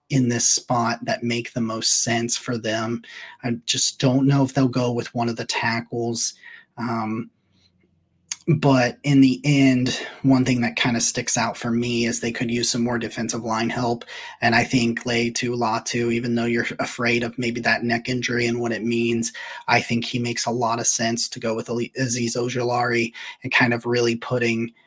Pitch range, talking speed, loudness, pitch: 115-125 Hz, 200 wpm, -21 LUFS, 120 Hz